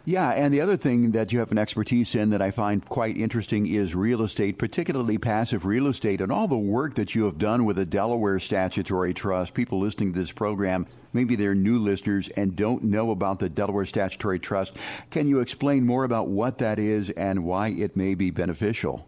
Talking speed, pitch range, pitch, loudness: 210 wpm, 100-120 Hz, 105 Hz, -25 LUFS